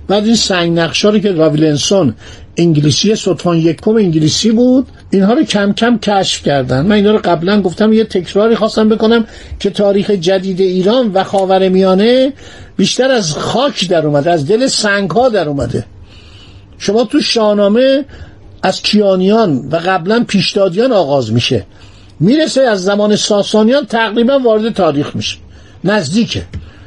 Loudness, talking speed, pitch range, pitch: -11 LUFS, 145 wpm, 160-220 Hz, 200 Hz